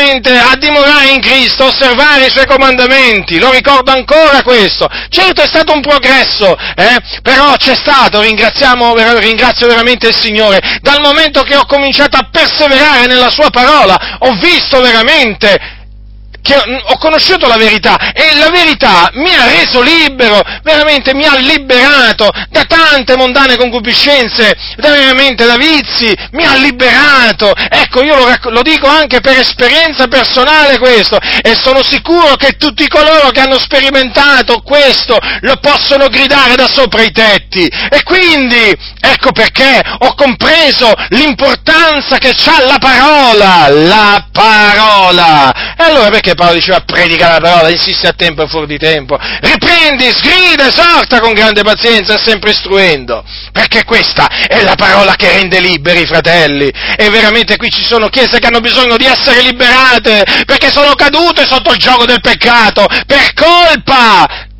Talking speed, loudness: 150 wpm, -5 LUFS